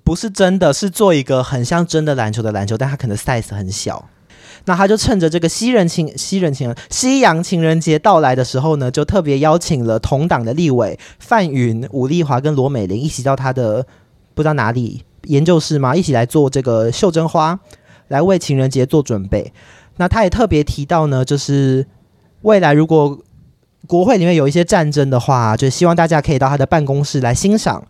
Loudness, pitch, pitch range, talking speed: -15 LUFS, 145 Hz, 130-170 Hz, 310 characters per minute